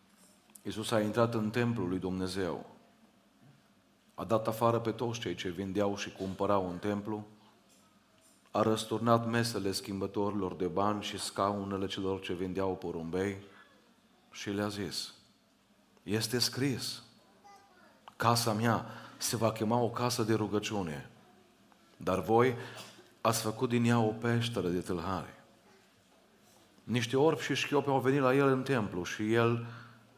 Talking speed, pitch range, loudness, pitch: 135 wpm, 100-120 Hz, -32 LUFS, 110 Hz